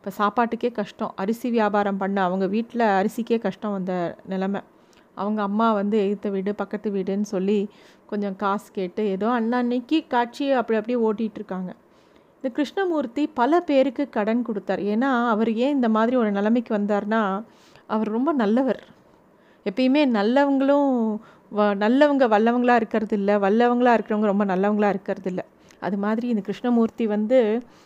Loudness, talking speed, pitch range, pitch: -23 LUFS, 140 wpm, 205-245 Hz, 220 Hz